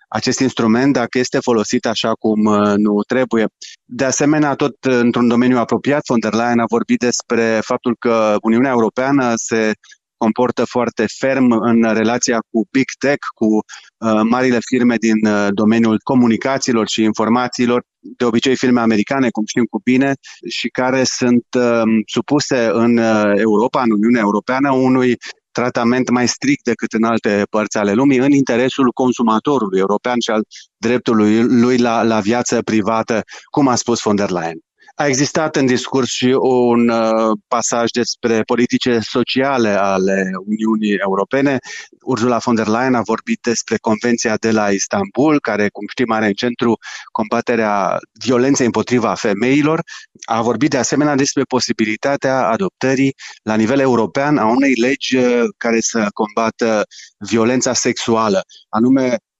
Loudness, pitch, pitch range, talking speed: -16 LUFS, 120 Hz, 110-130 Hz, 145 wpm